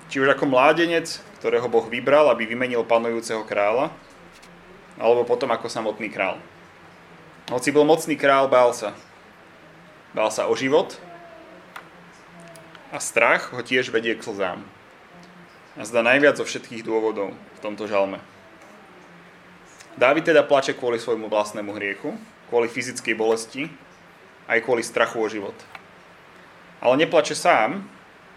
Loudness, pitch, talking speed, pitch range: -21 LUFS, 115 Hz, 125 wpm, 110-135 Hz